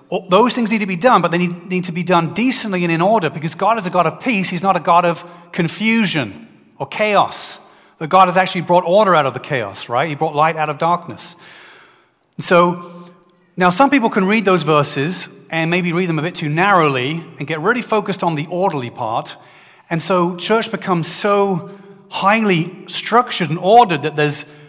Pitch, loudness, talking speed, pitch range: 175 Hz, -16 LUFS, 205 wpm, 160-195 Hz